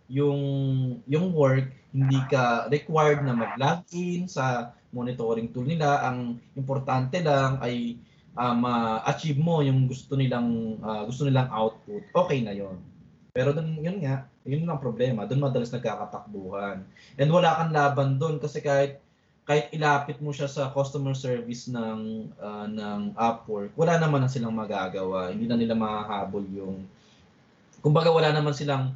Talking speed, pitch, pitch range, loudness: 145 wpm, 130 Hz, 115-145 Hz, -26 LUFS